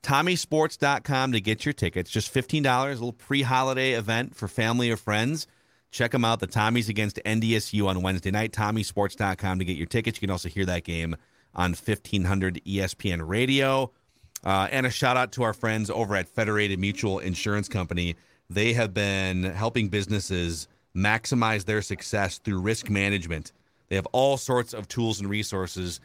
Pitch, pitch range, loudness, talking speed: 105 Hz, 95-120 Hz, -26 LUFS, 170 wpm